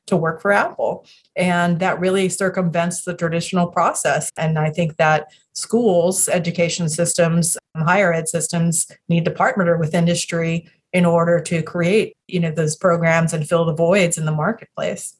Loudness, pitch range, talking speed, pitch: -18 LUFS, 165-180 Hz, 160 wpm, 170 Hz